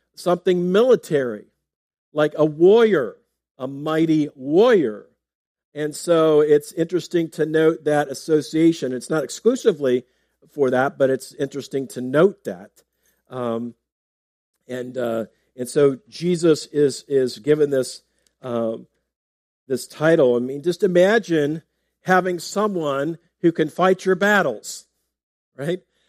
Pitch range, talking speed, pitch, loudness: 125-175 Hz, 120 wpm, 150 Hz, -20 LUFS